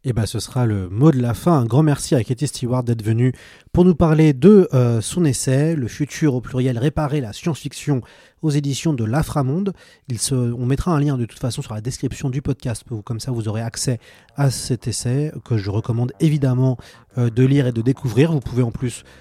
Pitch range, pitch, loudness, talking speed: 120-145 Hz, 130 Hz, -19 LUFS, 225 wpm